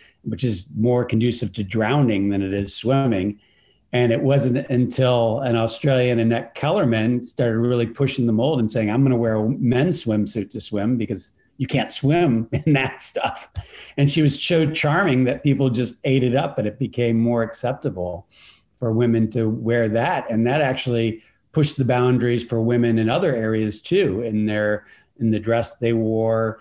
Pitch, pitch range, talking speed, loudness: 120 Hz, 110-130 Hz, 180 wpm, -20 LUFS